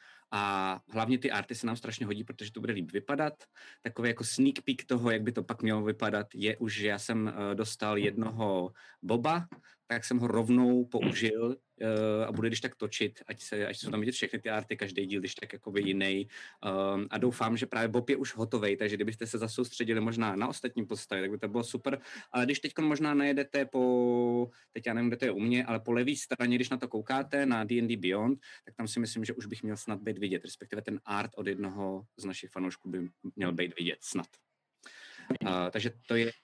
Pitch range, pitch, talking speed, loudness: 105-125 Hz, 115 Hz, 220 wpm, -33 LUFS